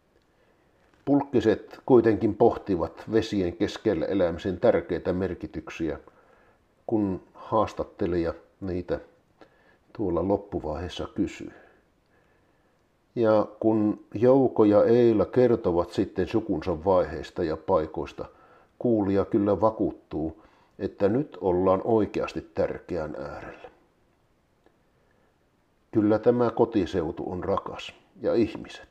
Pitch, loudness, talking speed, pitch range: 110 Hz, -26 LUFS, 85 wpm, 100-120 Hz